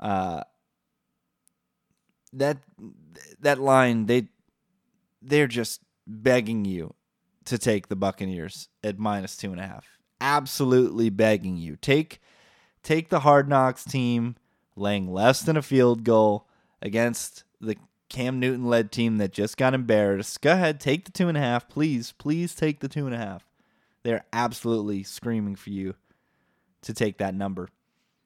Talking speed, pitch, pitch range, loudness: 145 wpm, 115 Hz, 105-135 Hz, -25 LUFS